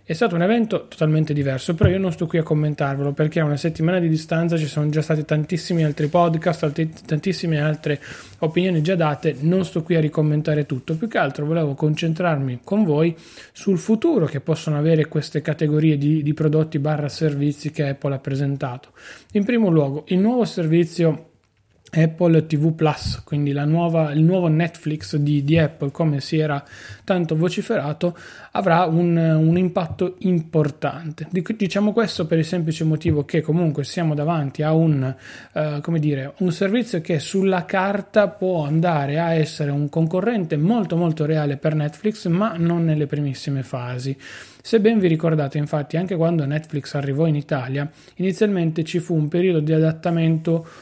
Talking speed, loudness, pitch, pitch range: 170 wpm, -21 LUFS, 160 Hz, 150-175 Hz